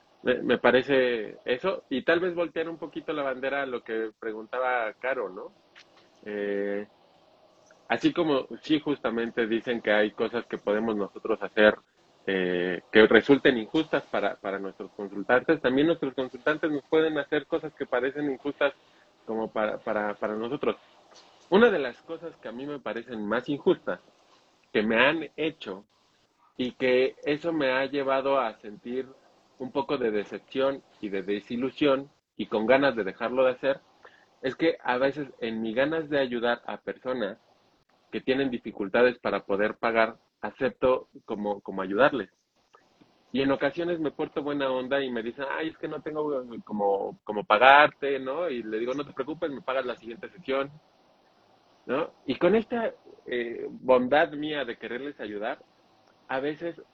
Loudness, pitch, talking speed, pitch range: -27 LUFS, 130 Hz, 160 wpm, 110-150 Hz